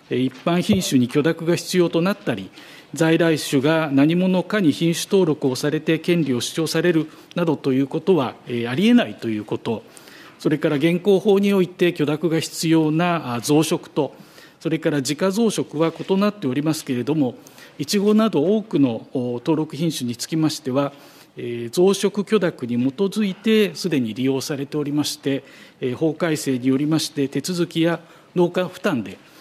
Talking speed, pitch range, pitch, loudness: 320 characters per minute, 140-180 Hz, 160 Hz, -21 LUFS